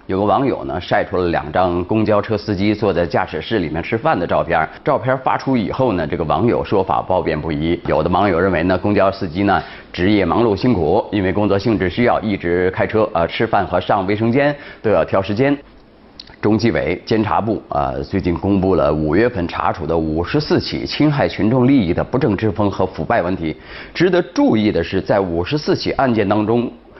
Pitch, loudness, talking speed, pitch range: 105 Hz, -17 LUFS, 315 characters per minute, 90-115 Hz